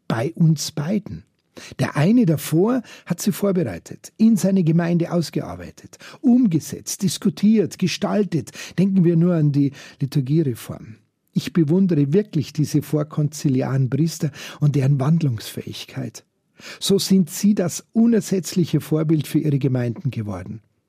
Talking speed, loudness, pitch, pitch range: 120 wpm, -20 LUFS, 160 Hz, 145-190 Hz